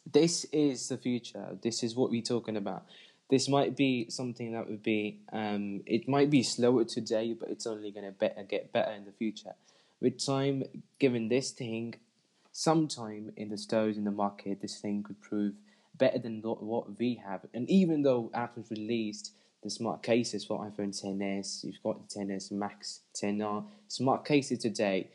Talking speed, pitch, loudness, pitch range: 180 wpm, 115 Hz, -32 LUFS, 105-125 Hz